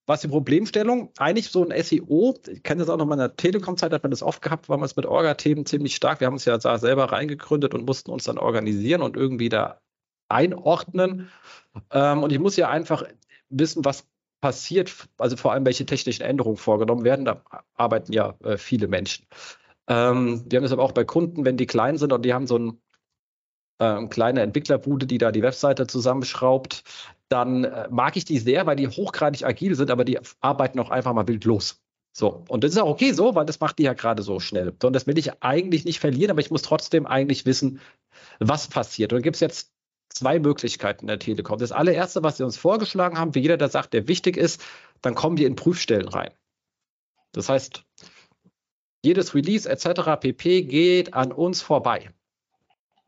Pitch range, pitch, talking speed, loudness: 125-165 Hz, 140 Hz, 200 wpm, -23 LUFS